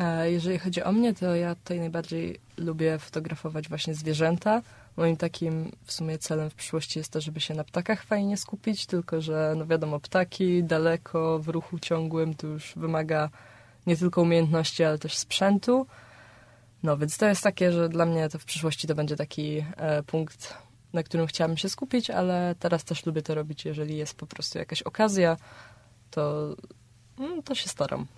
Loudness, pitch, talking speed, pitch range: -28 LUFS, 160 Hz, 170 wpm, 155-175 Hz